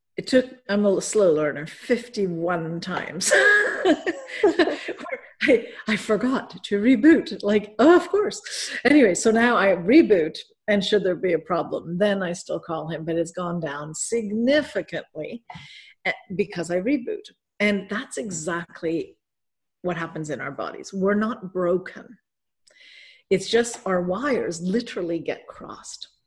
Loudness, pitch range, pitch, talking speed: -23 LUFS, 180-265 Hz, 205 Hz, 135 wpm